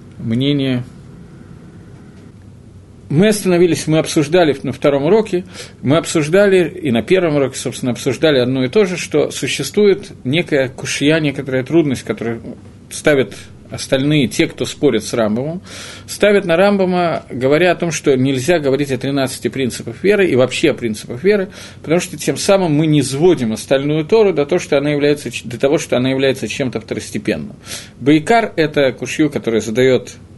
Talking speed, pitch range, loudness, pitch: 150 wpm, 120-165 Hz, -15 LUFS, 140 Hz